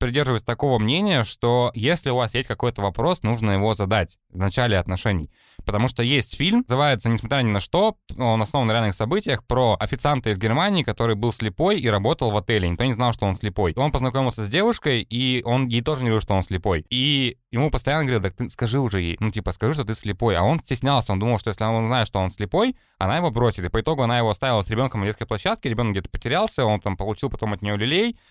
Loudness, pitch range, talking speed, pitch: -22 LUFS, 105-135 Hz, 235 wpm, 120 Hz